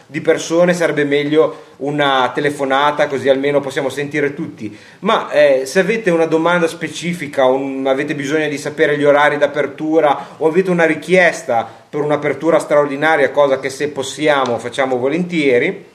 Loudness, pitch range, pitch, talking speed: -15 LUFS, 135-160 Hz, 145 Hz, 145 wpm